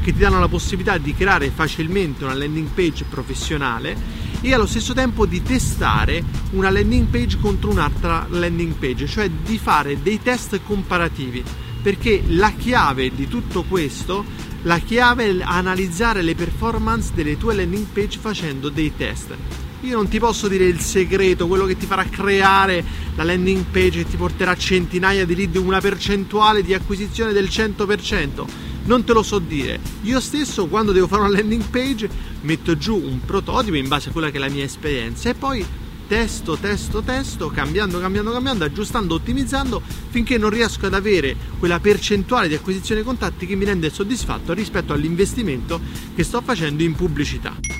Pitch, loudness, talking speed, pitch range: 190 Hz, -20 LUFS, 170 wpm, 155-210 Hz